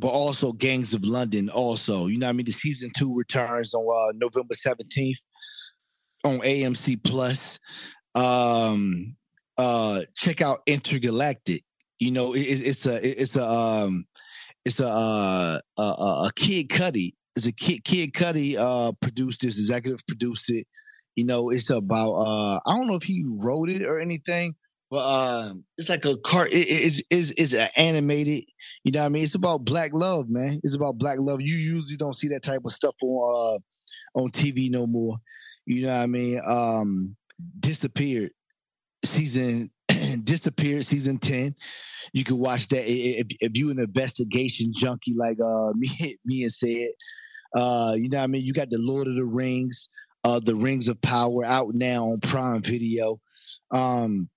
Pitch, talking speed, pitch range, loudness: 130 Hz, 180 wpm, 120-145 Hz, -25 LUFS